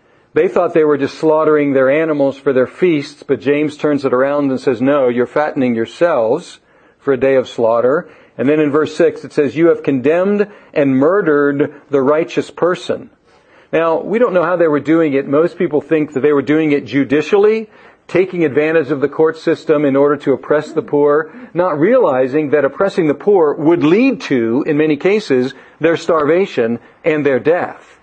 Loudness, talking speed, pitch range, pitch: -14 LUFS, 190 wpm, 140-165 Hz, 150 Hz